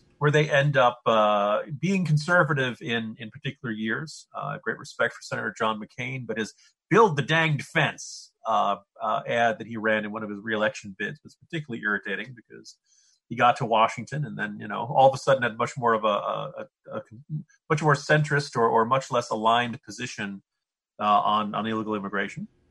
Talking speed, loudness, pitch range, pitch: 195 wpm, -25 LUFS, 110-145 Hz, 120 Hz